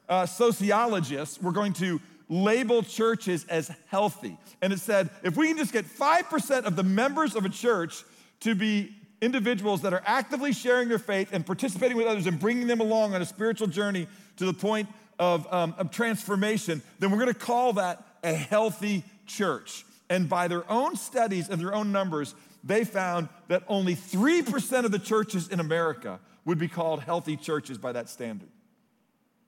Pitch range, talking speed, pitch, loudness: 180-230 Hz, 180 wpm, 205 Hz, -27 LUFS